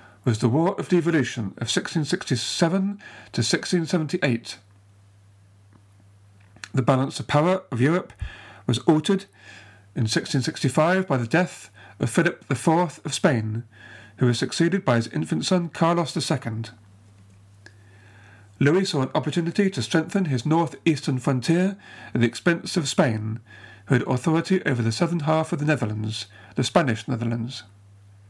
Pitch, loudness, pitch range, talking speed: 130 Hz, -23 LUFS, 105-165 Hz, 135 wpm